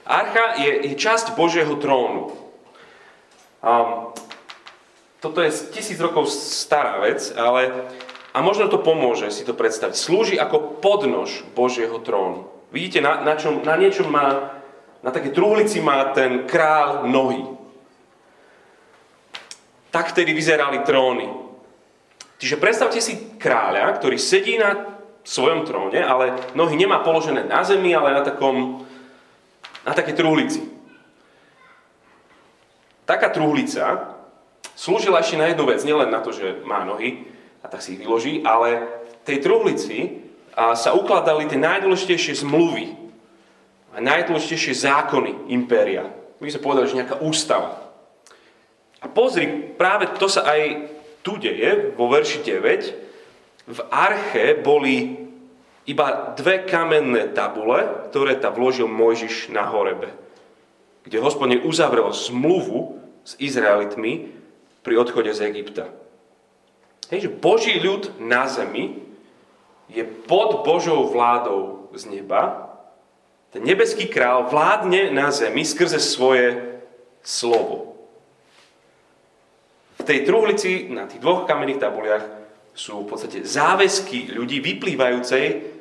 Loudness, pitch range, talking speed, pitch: -20 LUFS, 125-210 Hz, 120 wpm, 150 Hz